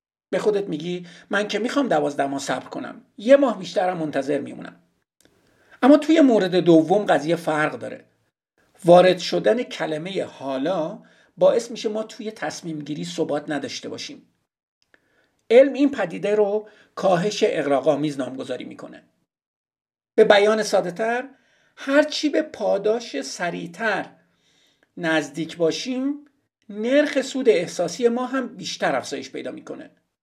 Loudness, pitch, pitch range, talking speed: -21 LUFS, 210 Hz, 165-250 Hz, 125 wpm